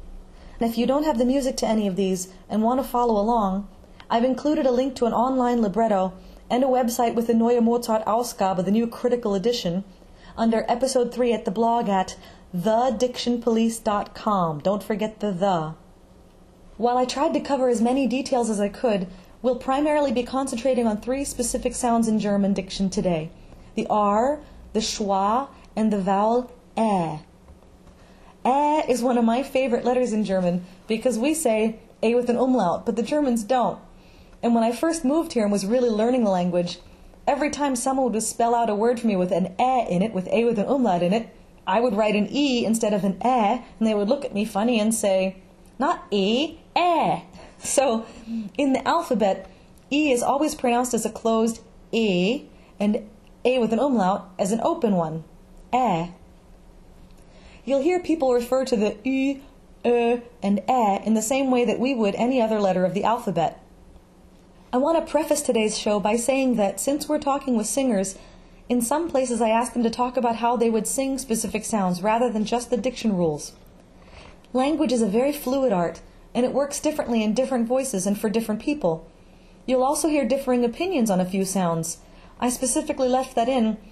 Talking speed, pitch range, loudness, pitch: 195 wpm, 205-255 Hz, -23 LUFS, 235 Hz